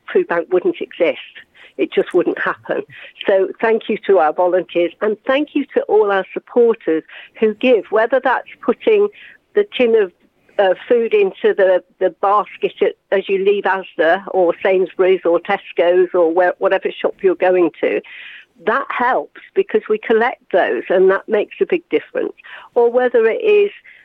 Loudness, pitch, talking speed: -16 LUFS, 230 Hz, 165 wpm